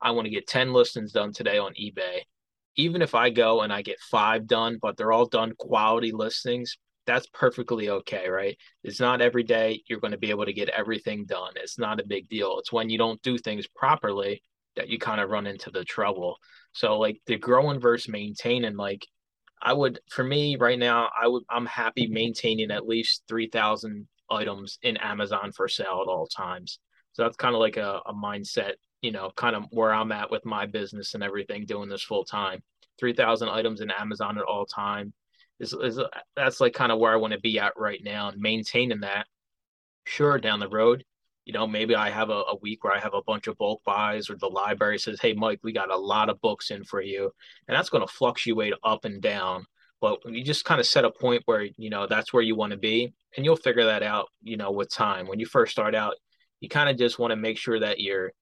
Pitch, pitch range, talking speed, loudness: 115 Hz, 105-125 Hz, 230 wpm, -26 LUFS